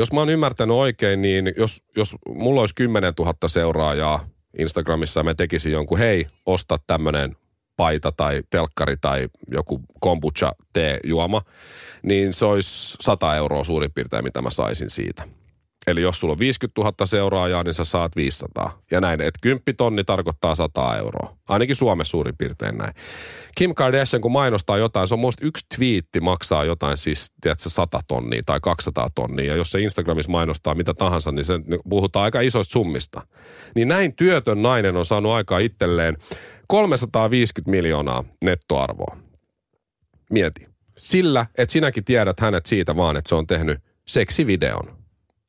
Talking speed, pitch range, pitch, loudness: 155 wpm, 80-115 Hz, 95 Hz, -21 LUFS